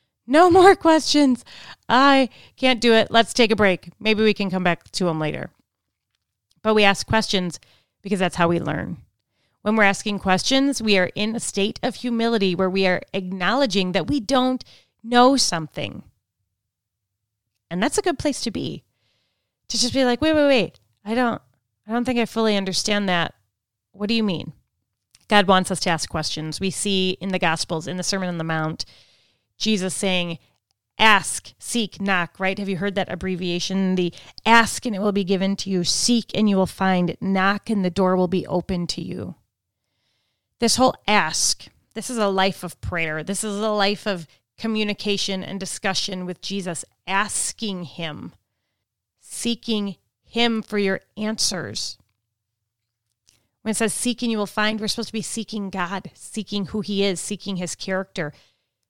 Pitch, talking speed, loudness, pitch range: 190 Hz, 175 wpm, -21 LUFS, 155-215 Hz